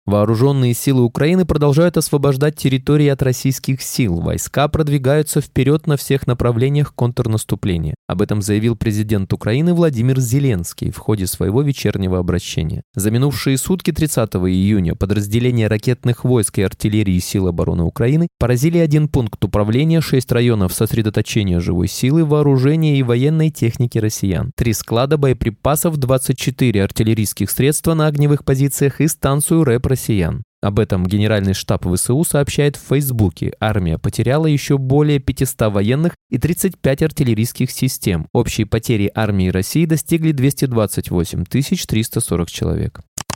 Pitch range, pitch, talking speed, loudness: 105-145 Hz, 125 Hz, 130 wpm, -17 LUFS